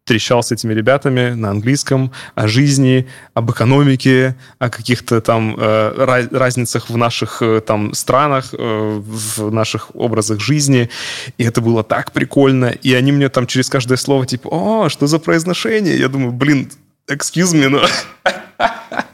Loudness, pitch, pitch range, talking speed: -15 LUFS, 125 Hz, 115-135 Hz, 150 wpm